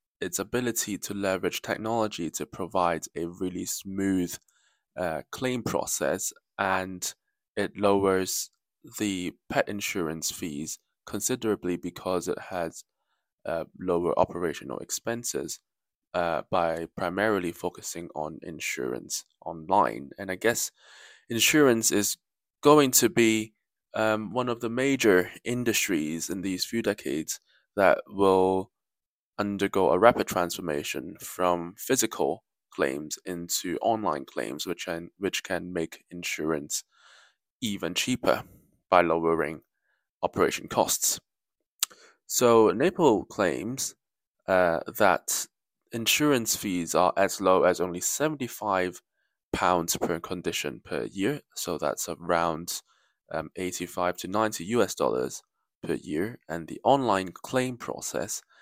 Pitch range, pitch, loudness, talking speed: 90-115 Hz, 95 Hz, -27 LUFS, 115 wpm